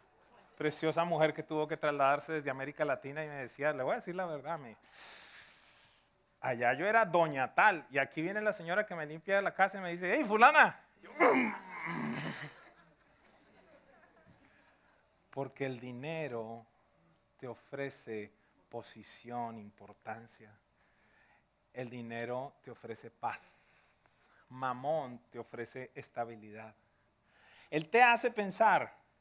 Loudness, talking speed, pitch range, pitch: -33 LUFS, 120 wpm, 120-165 Hz, 140 Hz